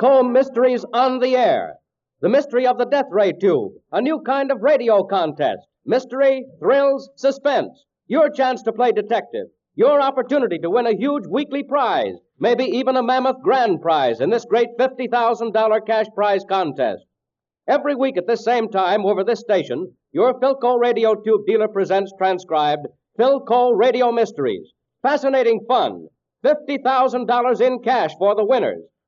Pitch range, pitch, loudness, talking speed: 220-275 Hz, 250 Hz, -19 LUFS, 155 wpm